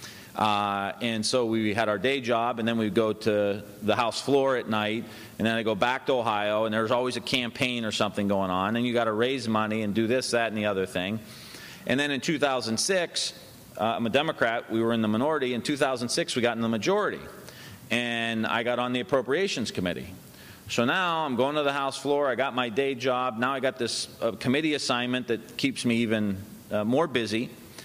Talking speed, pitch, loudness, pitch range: 220 wpm, 120 Hz, -27 LUFS, 110-130 Hz